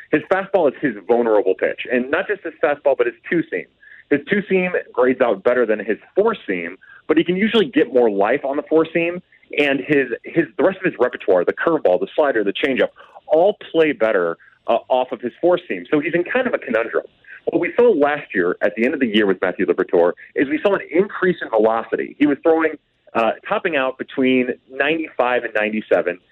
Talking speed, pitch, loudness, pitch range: 215 wpm, 165 Hz, -19 LUFS, 135-220 Hz